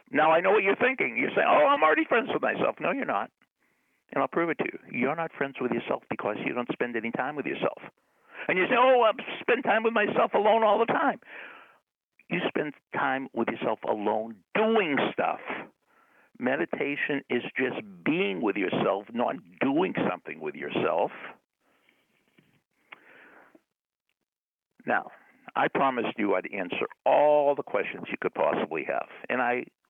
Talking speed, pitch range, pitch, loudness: 165 wpm, 135-225 Hz, 165 Hz, -27 LUFS